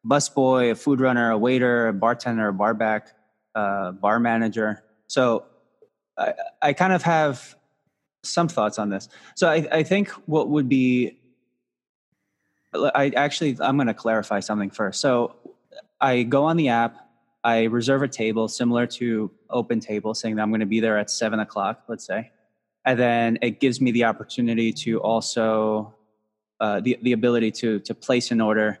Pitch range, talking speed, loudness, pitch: 110-130 Hz, 175 wpm, -22 LUFS, 115 Hz